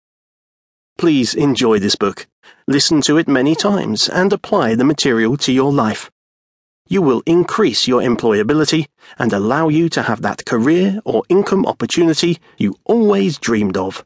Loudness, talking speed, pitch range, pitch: -15 LUFS, 150 wpm, 135-190 Hz, 160 Hz